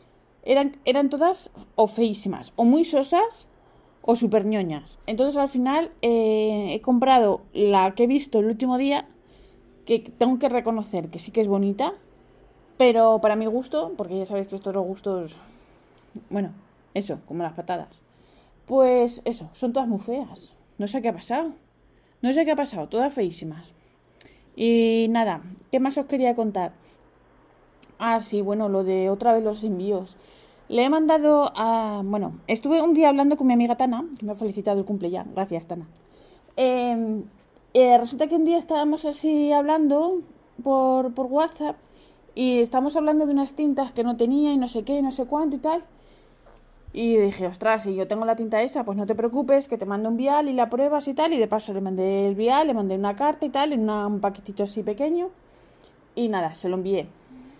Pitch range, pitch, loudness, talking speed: 205-280 Hz, 235 Hz, -23 LUFS, 190 wpm